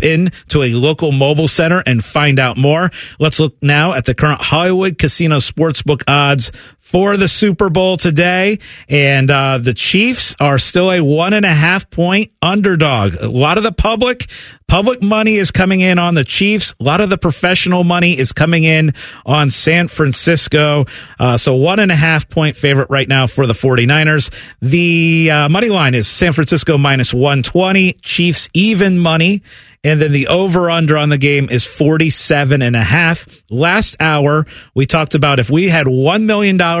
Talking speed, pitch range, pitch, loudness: 185 wpm, 140-180 Hz, 155 Hz, -12 LUFS